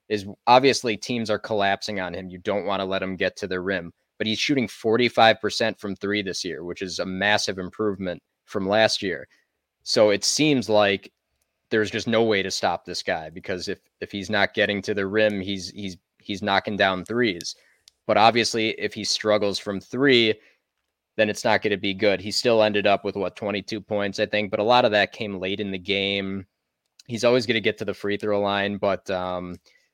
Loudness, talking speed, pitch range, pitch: -23 LUFS, 210 wpm, 95-110 Hz, 100 Hz